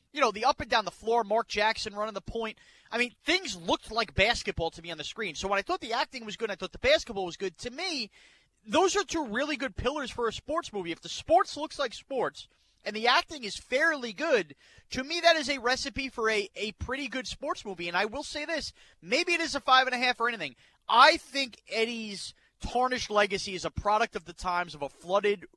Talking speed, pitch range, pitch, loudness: 245 wpm, 205-290 Hz, 235 Hz, -29 LUFS